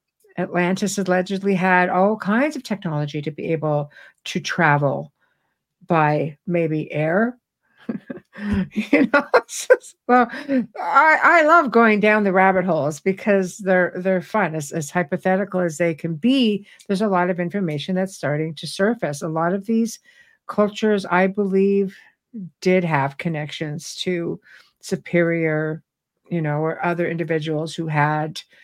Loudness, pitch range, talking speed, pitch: -20 LUFS, 165-210 Hz, 140 wpm, 185 Hz